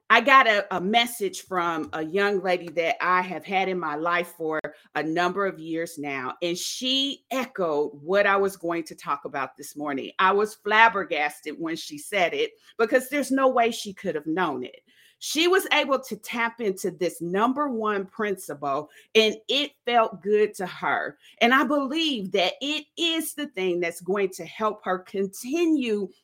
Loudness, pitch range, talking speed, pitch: -25 LUFS, 175-240 Hz, 185 wpm, 195 Hz